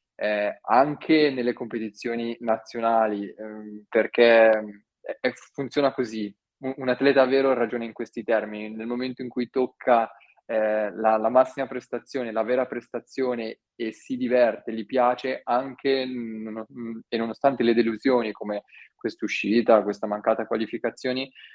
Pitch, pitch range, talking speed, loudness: 120 Hz, 110-130 Hz, 130 wpm, -25 LUFS